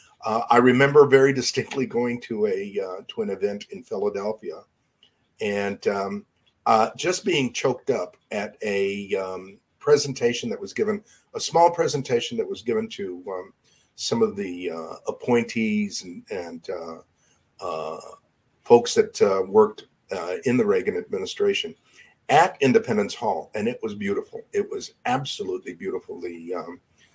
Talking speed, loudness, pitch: 150 wpm, -24 LUFS, 185 Hz